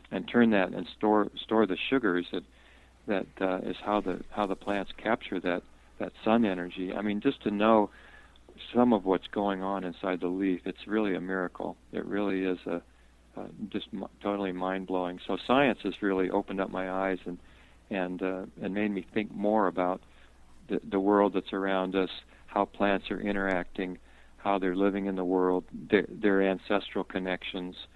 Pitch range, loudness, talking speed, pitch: 90-100 Hz, -30 LUFS, 180 wpm, 95 Hz